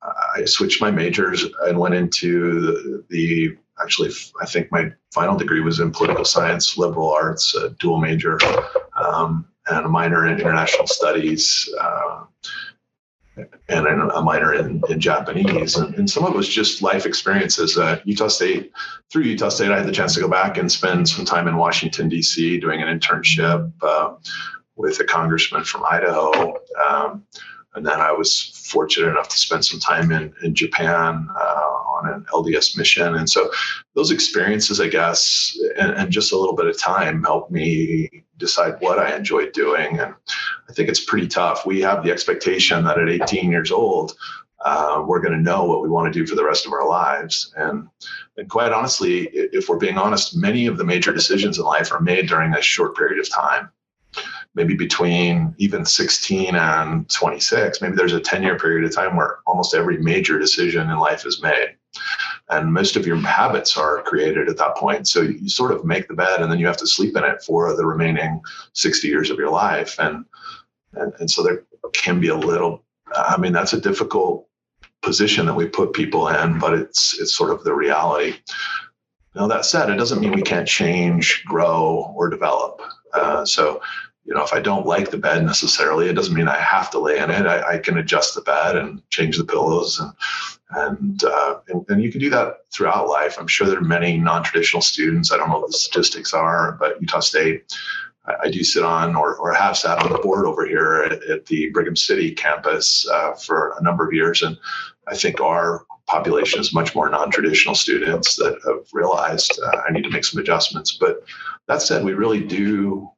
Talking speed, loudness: 200 wpm, -18 LUFS